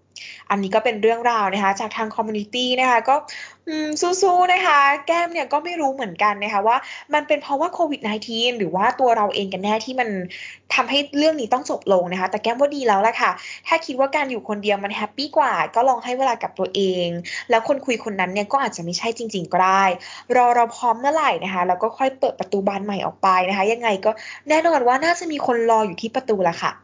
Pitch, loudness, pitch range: 235 Hz, -20 LUFS, 205-280 Hz